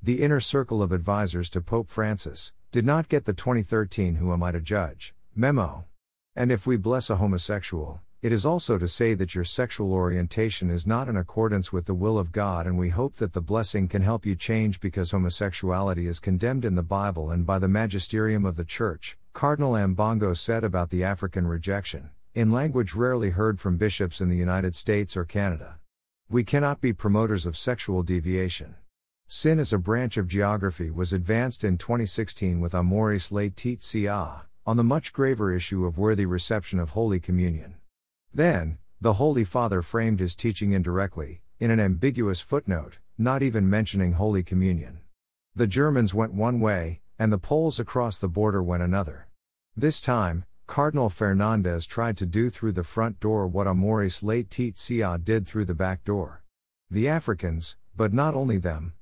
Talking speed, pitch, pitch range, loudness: 175 wpm, 100 Hz, 90-115 Hz, -26 LUFS